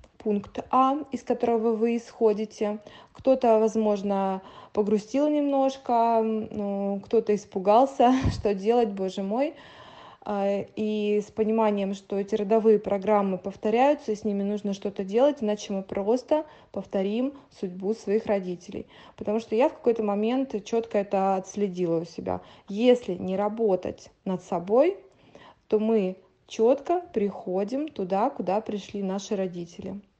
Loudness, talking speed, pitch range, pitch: -26 LUFS, 125 wpm, 200-230 Hz, 210 Hz